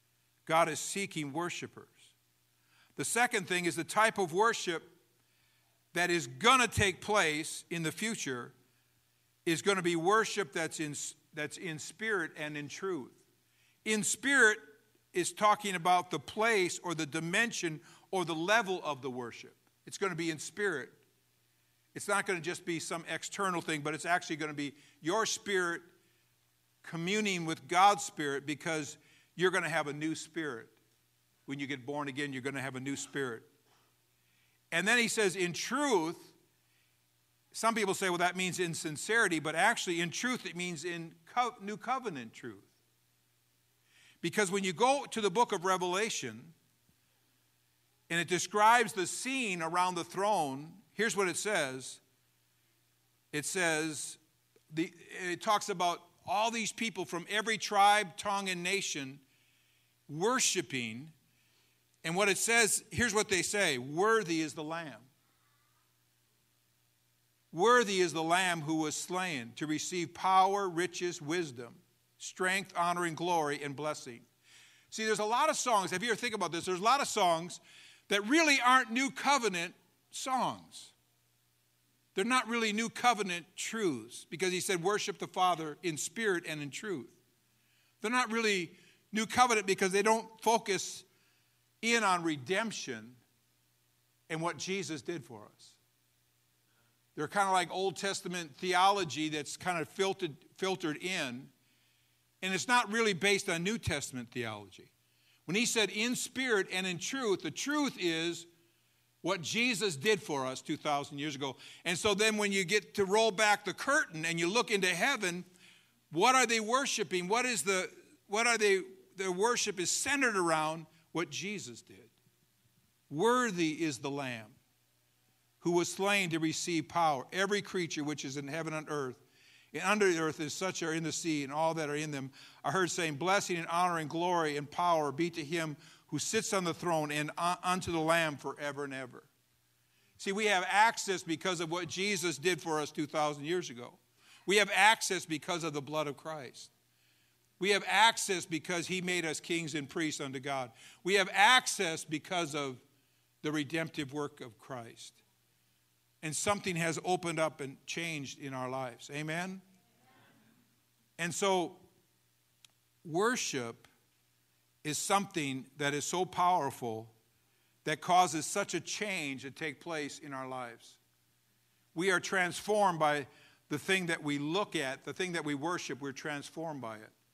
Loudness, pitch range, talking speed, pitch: -32 LUFS, 140-195 Hz, 160 wpm, 165 Hz